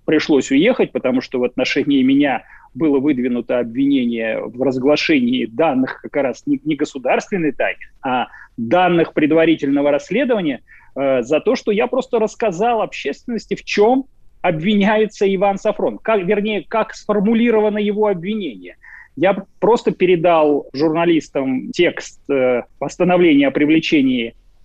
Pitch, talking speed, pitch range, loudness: 200 Hz, 120 wpm, 150-235 Hz, -17 LUFS